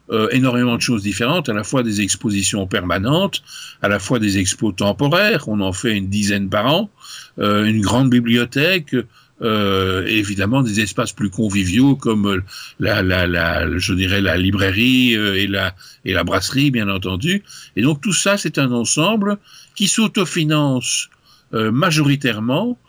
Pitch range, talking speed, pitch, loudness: 100-135 Hz, 165 wpm, 110 Hz, -17 LUFS